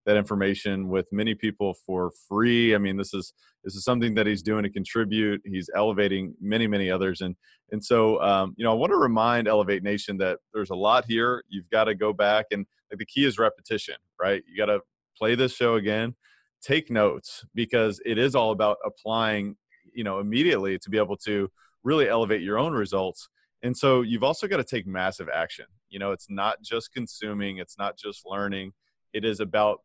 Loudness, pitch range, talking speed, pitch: -26 LUFS, 100-110 Hz, 205 wpm, 105 Hz